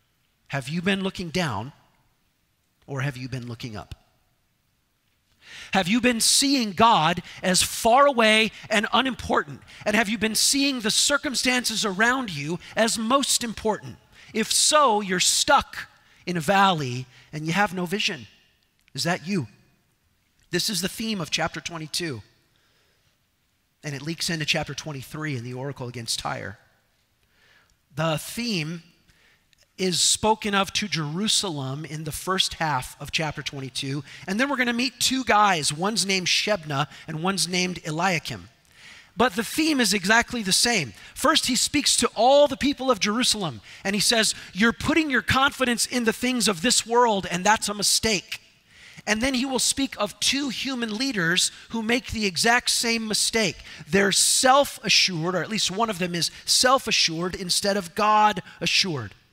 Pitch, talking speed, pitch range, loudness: 195 Hz, 160 wpm, 155-230 Hz, -22 LUFS